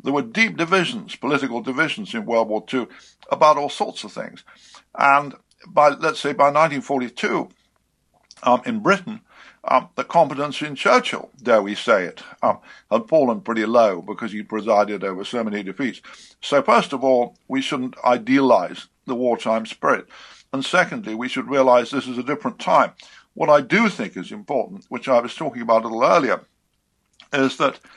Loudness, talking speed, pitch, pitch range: -20 LUFS, 175 wpm, 135 Hz, 120-155 Hz